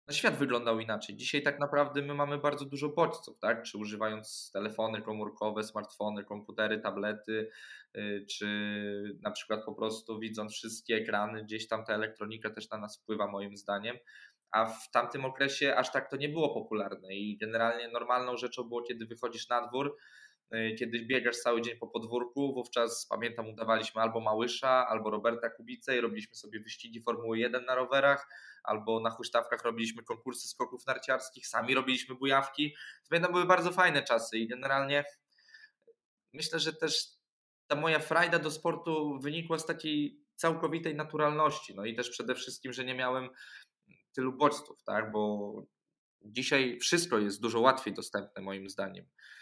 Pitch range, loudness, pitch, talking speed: 110-145 Hz, -33 LUFS, 120 Hz, 160 wpm